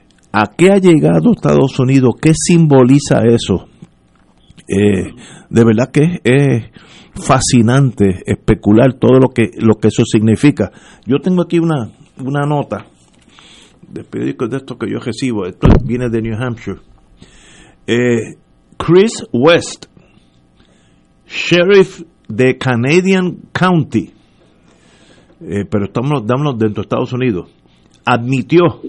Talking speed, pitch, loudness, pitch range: 115 wpm, 125 Hz, -13 LUFS, 105-145 Hz